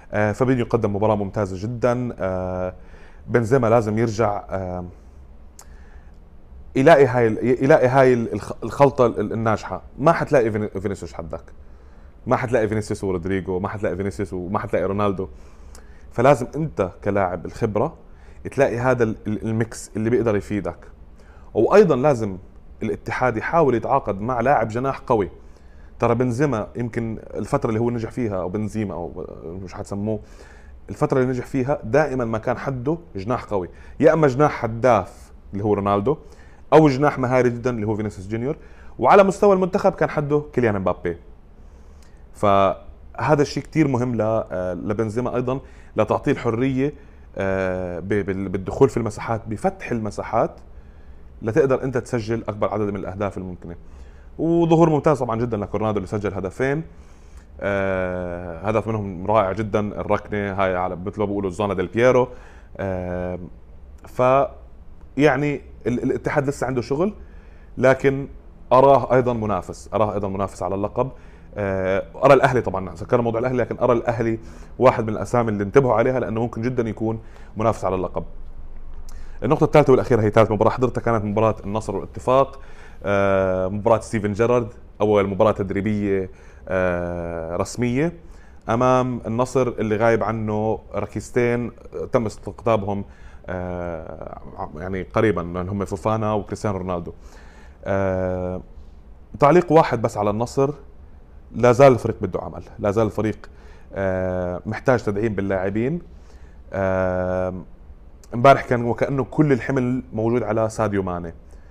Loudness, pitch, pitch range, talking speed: -21 LUFS, 105 Hz, 90-120 Hz, 125 wpm